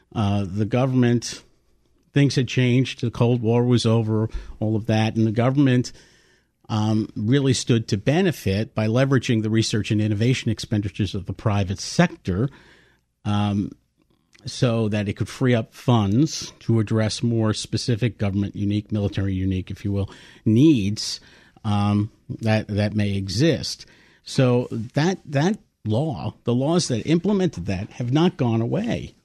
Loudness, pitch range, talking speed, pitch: -22 LUFS, 105-130 Hz, 145 wpm, 115 Hz